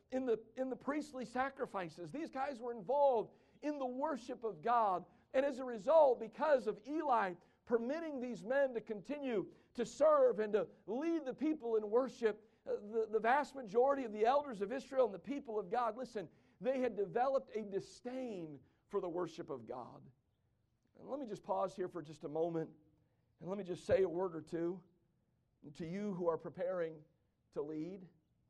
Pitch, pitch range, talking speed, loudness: 225 Hz, 180-260 Hz, 185 wpm, -38 LUFS